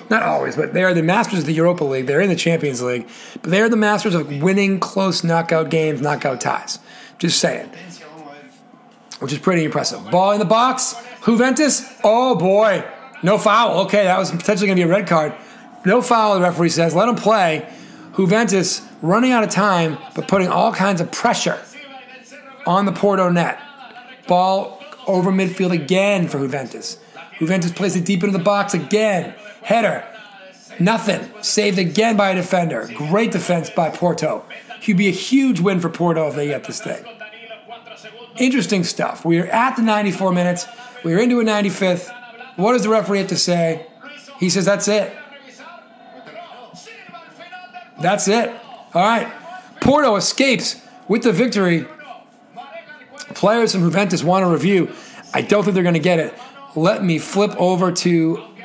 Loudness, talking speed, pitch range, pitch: -17 LUFS, 170 wpm, 175-235 Hz, 200 Hz